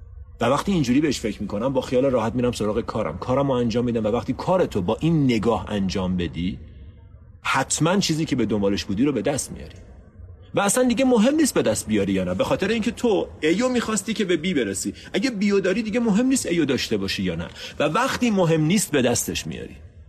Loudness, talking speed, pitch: -22 LUFS, 220 wpm, 120 Hz